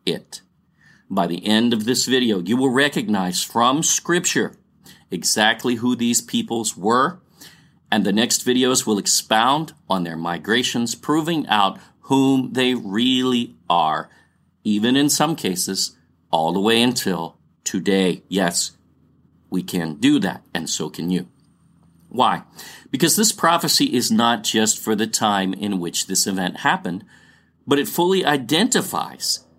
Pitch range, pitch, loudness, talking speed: 95-135 Hz, 115 Hz, -19 LUFS, 140 wpm